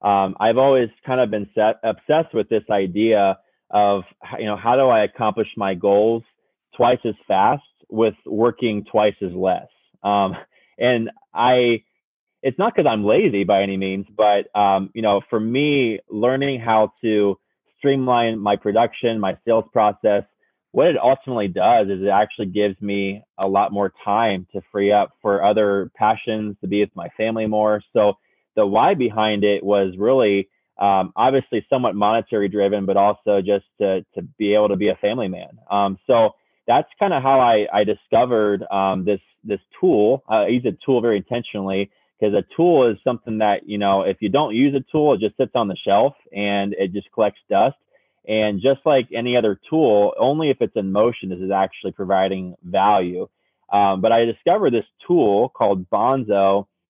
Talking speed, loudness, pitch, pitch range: 180 wpm, -19 LUFS, 105 Hz, 100-115 Hz